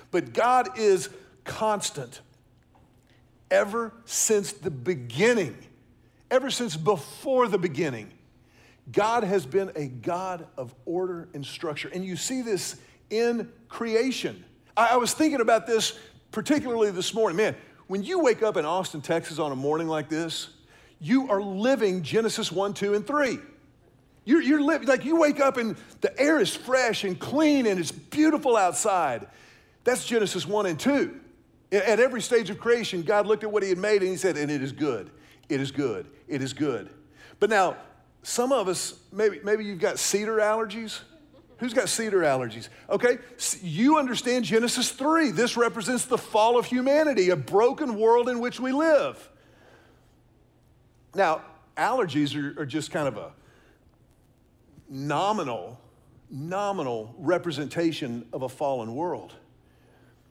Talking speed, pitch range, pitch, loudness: 155 wpm, 150-240 Hz, 200 Hz, -25 LUFS